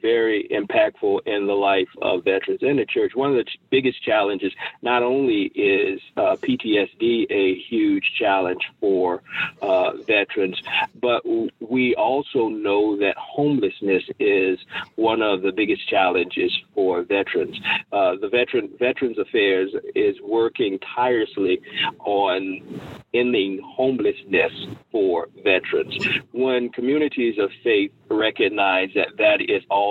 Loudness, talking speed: -21 LUFS, 130 wpm